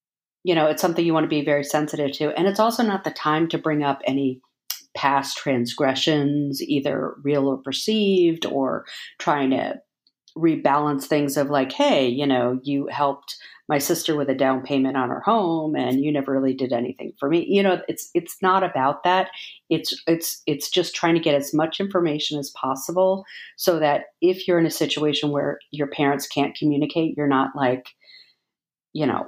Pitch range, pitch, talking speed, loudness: 140-170 Hz, 150 Hz, 190 wpm, -22 LUFS